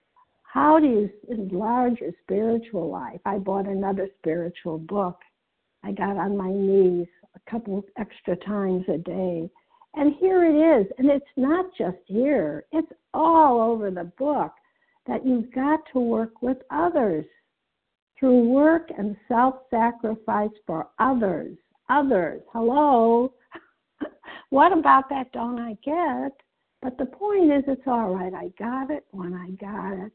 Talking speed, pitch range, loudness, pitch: 145 wpm, 195-285 Hz, -23 LUFS, 235 Hz